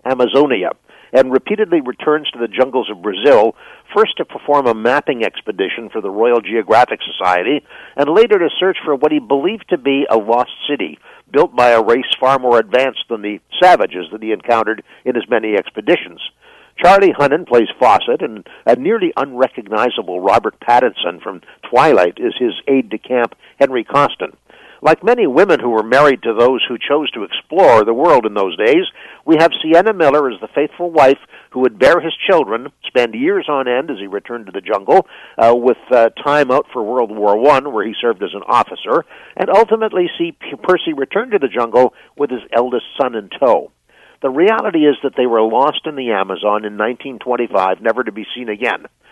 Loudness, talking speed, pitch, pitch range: -14 LUFS, 190 wpm, 145 Hz, 120-200 Hz